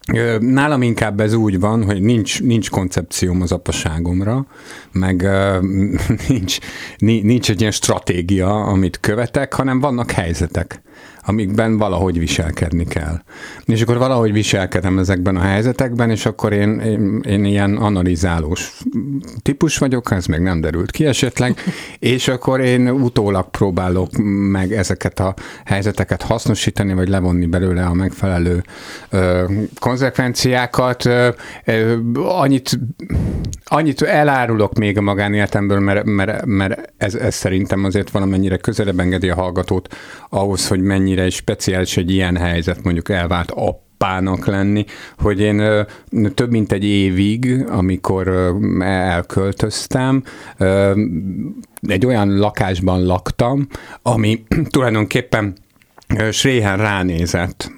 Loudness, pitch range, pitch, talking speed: -17 LUFS, 95-120 Hz, 105 Hz, 115 wpm